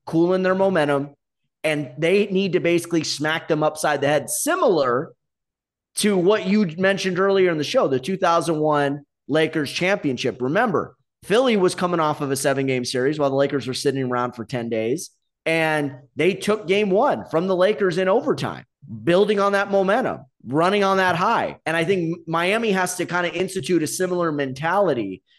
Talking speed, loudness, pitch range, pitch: 175 wpm, -21 LUFS, 145-190 Hz, 170 Hz